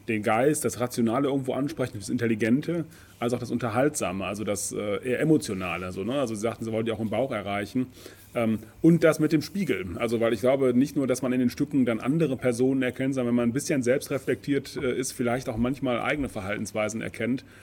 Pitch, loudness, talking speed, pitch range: 120 Hz, -27 LUFS, 210 wpm, 110-130 Hz